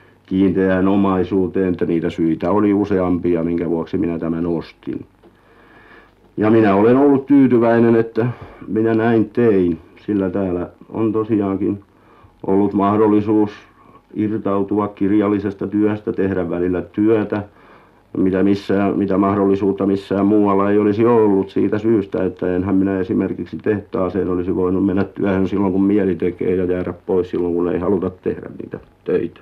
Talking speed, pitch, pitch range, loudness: 135 wpm, 100 Hz, 90-105 Hz, -17 LUFS